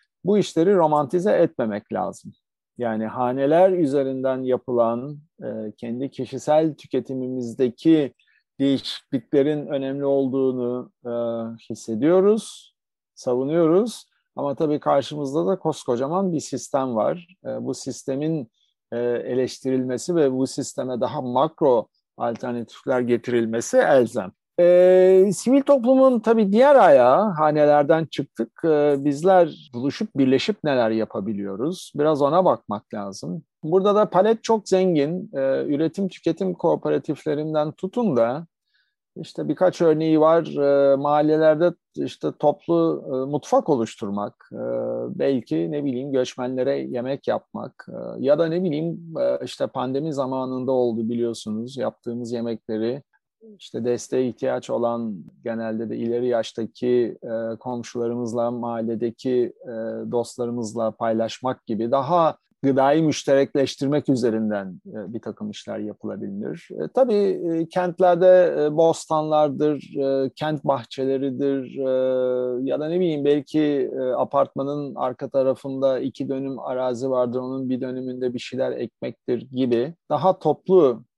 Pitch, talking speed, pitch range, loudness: 135 Hz, 110 wpm, 120-160 Hz, -22 LUFS